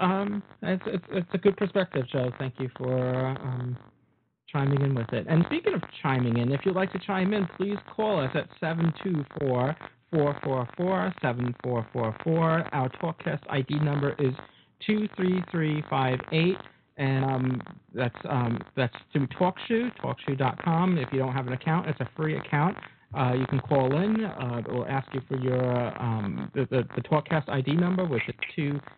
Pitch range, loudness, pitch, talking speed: 130-175 Hz, -28 LUFS, 145 Hz, 165 wpm